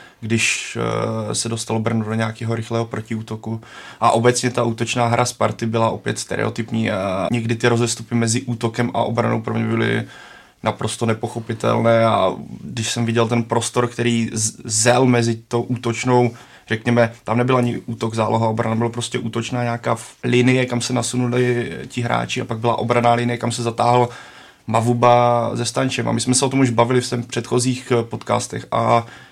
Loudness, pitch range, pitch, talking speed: -19 LUFS, 115-120 Hz, 120 Hz, 170 wpm